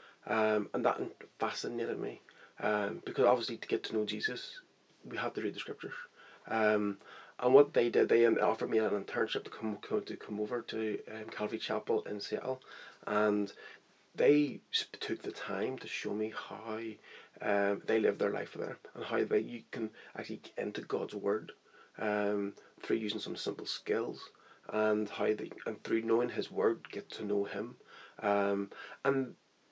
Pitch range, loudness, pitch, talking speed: 105-120 Hz, -34 LUFS, 110 Hz, 175 wpm